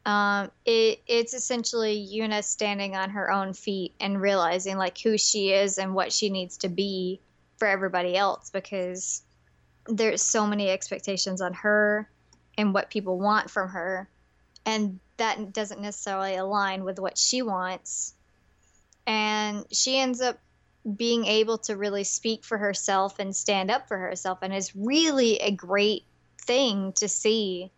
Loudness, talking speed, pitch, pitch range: -26 LUFS, 155 wpm, 200 Hz, 190-215 Hz